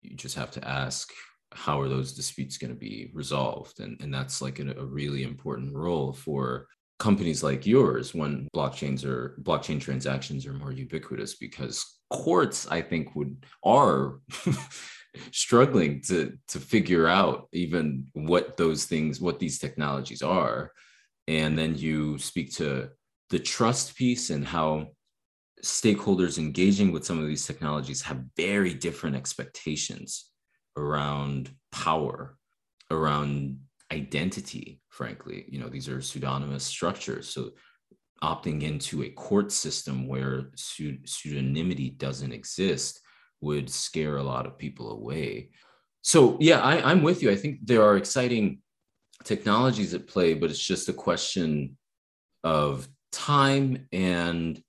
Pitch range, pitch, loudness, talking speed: 65-85 Hz, 75 Hz, -27 LUFS, 135 wpm